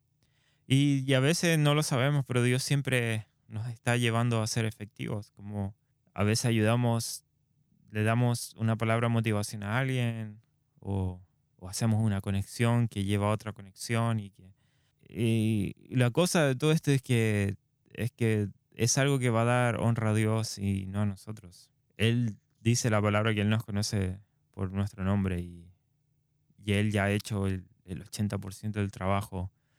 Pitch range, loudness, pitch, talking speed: 100-130 Hz, -29 LUFS, 110 Hz, 170 wpm